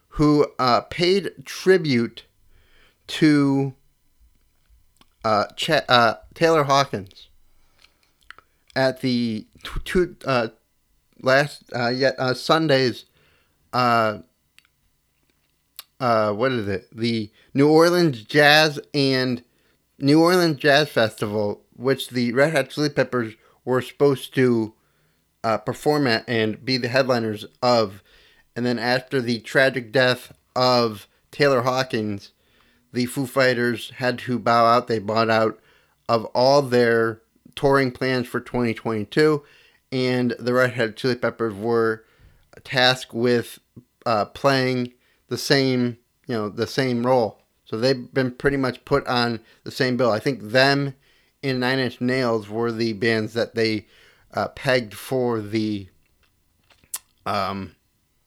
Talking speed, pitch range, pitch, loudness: 125 wpm, 110-135 Hz, 125 Hz, -21 LUFS